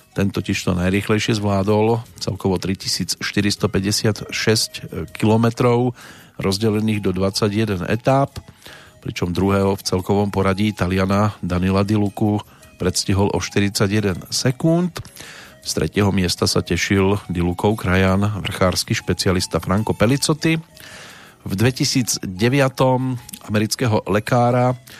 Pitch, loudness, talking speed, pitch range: 105 Hz, -19 LUFS, 95 wpm, 95-115 Hz